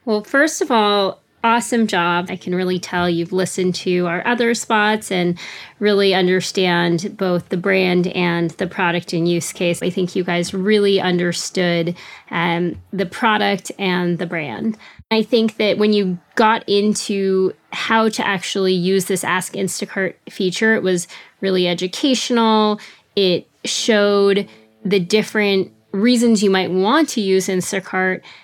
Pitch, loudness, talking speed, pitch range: 190 Hz, -18 LUFS, 150 wpm, 180-210 Hz